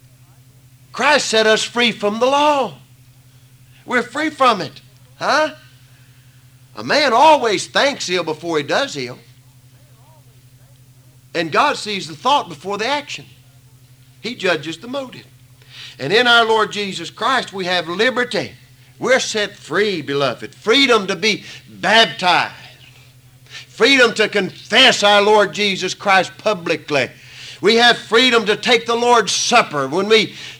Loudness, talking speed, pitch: -15 LUFS, 135 wpm, 170 Hz